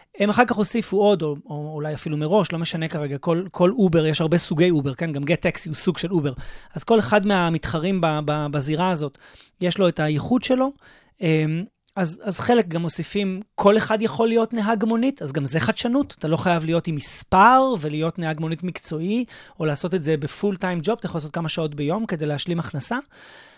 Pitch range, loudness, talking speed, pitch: 155-205 Hz, -22 LUFS, 200 wpm, 170 Hz